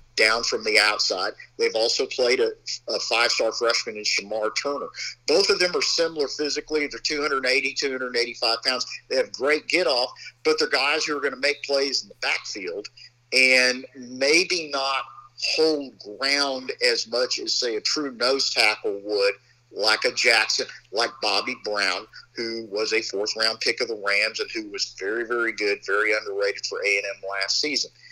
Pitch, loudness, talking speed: 155 Hz, -23 LUFS, 175 wpm